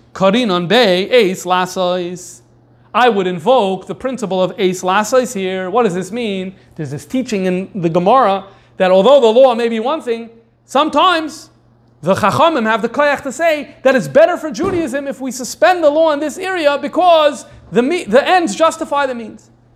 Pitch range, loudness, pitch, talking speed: 185-285 Hz, -14 LUFS, 235 Hz, 165 wpm